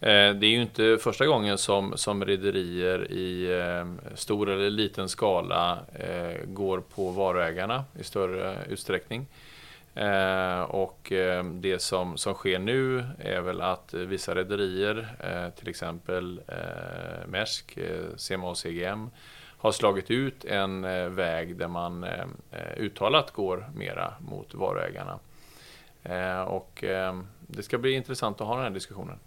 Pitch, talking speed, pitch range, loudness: 95 Hz, 120 wpm, 90-105 Hz, -29 LUFS